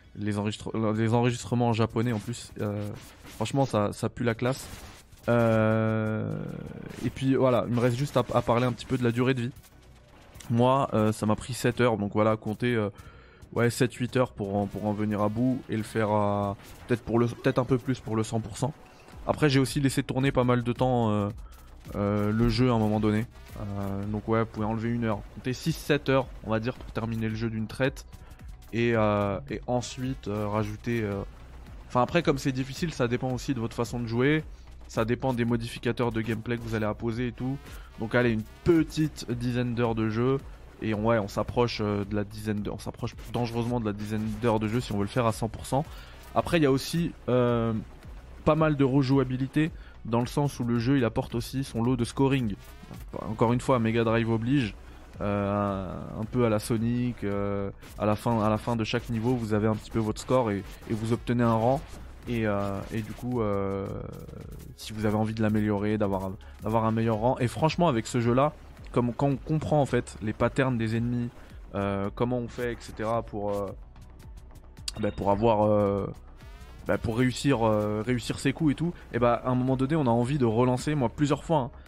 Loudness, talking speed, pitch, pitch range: -28 LUFS, 220 wpm, 115 Hz, 105-125 Hz